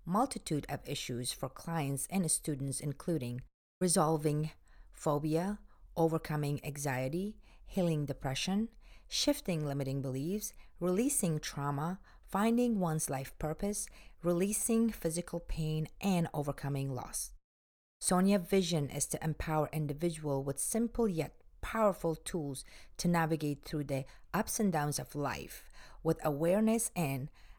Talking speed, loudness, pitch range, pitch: 115 wpm, -35 LUFS, 140-185 Hz, 155 Hz